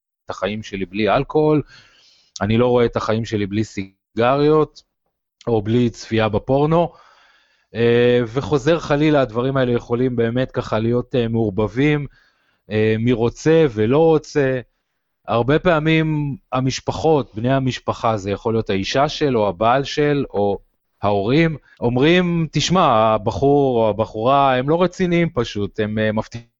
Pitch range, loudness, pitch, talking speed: 110-145 Hz, -18 LUFS, 120 Hz, 120 wpm